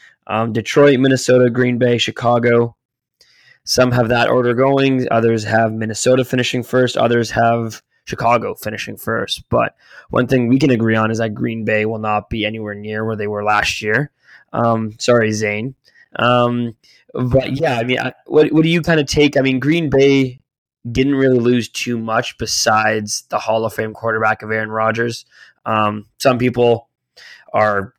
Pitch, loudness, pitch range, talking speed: 120 Hz, -16 LUFS, 110-130 Hz, 170 wpm